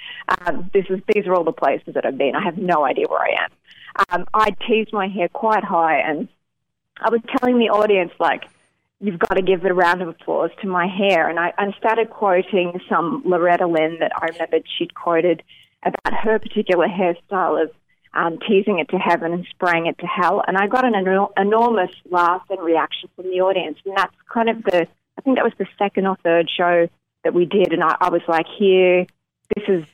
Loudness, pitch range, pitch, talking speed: -19 LUFS, 175-210 Hz, 185 Hz, 215 wpm